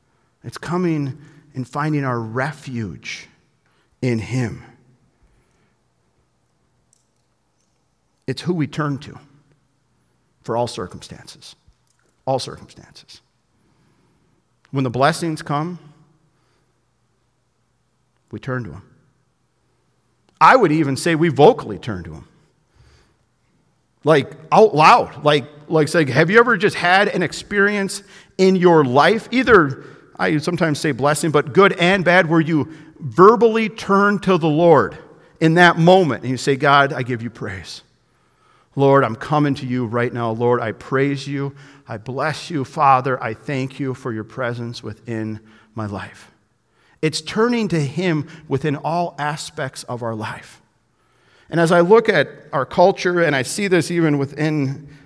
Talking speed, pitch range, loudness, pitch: 135 wpm, 125-165 Hz, -17 LUFS, 145 Hz